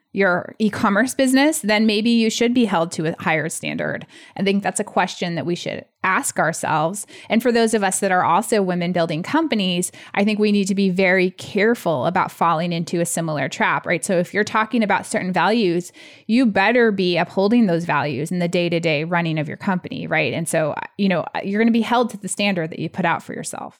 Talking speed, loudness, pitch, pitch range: 230 wpm, -19 LUFS, 190 Hz, 170-220 Hz